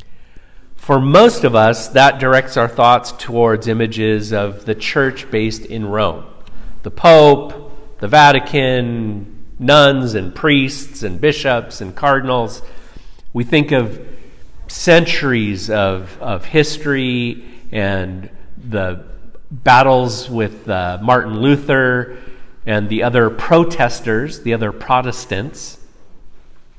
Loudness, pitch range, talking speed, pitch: -14 LUFS, 105-135 Hz, 110 wpm, 120 Hz